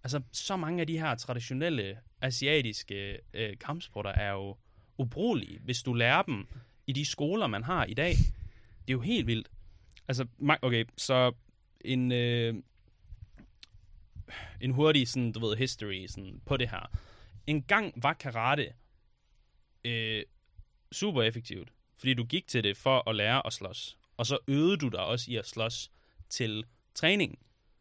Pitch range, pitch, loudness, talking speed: 100-130 Hz, 115 Hz, -31 LUFS, 155 wpm